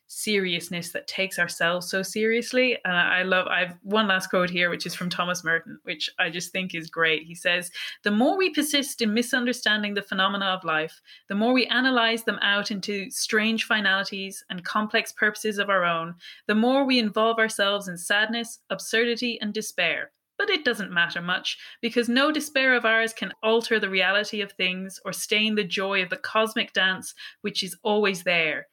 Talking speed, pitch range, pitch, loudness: 190 wpm, 185-225 Hz, 205 Hz, -24 LUFS